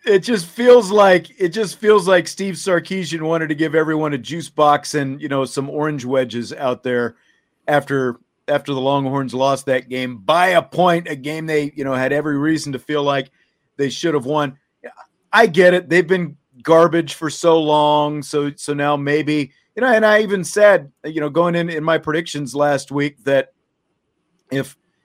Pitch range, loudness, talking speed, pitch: 140-170 Hz, -17 LUFS, 190 wpm, 150 Hz